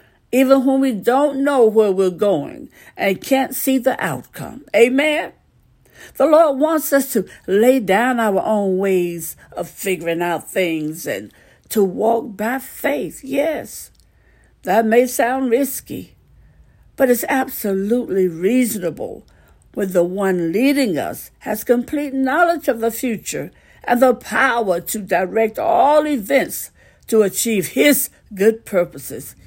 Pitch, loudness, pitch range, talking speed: 230 Hz, -18 LUFS, 195-270 Hz, 130 wpm